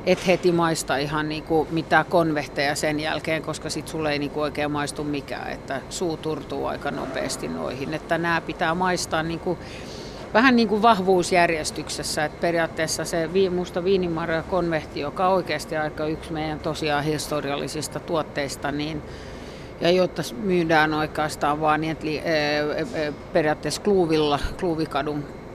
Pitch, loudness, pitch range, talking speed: 155 Hz, -24 LUFS, 150-170 Hz, 130 wpm